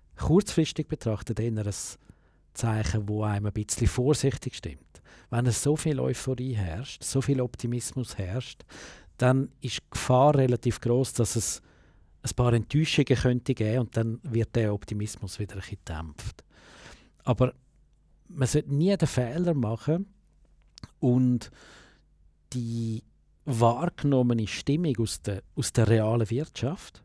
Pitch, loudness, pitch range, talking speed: 120 Hz, -27 LUFS, 110-135 Hz, 130 wpm